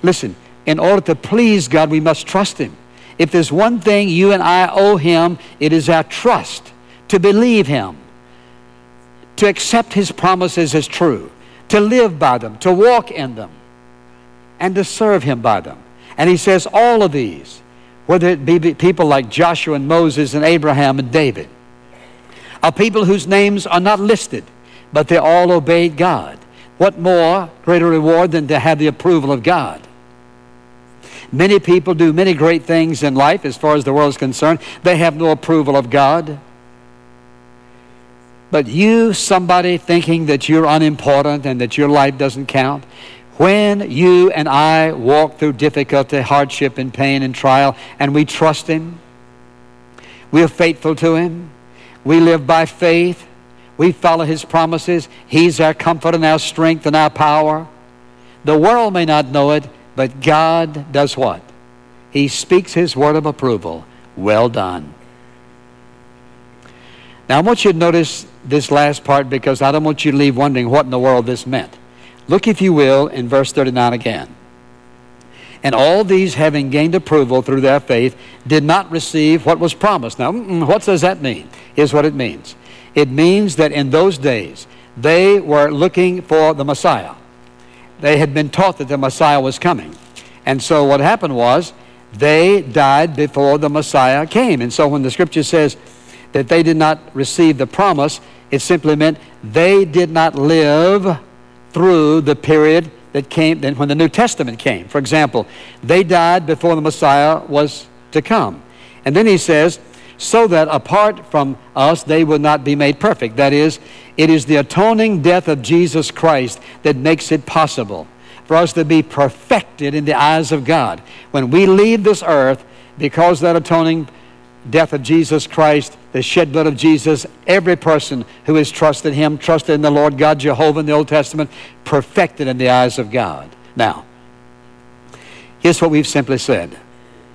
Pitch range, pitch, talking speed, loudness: 125-170 Hz, 150 Hz, 170 wpm, -13 LUFS